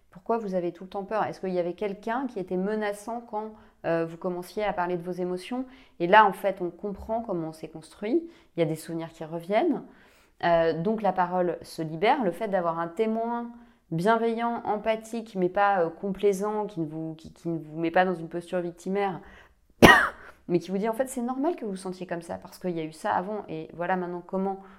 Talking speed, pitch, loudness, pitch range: 230 wpm, 190 Hz, -27 LUFS, 170-215 Hz